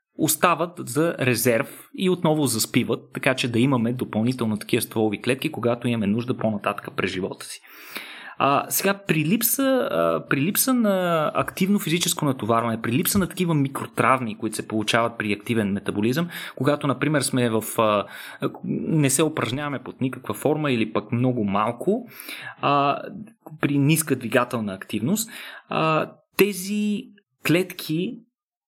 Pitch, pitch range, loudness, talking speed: 130 Hz, 115-175 Hz, -23 LUFS, 140 wpm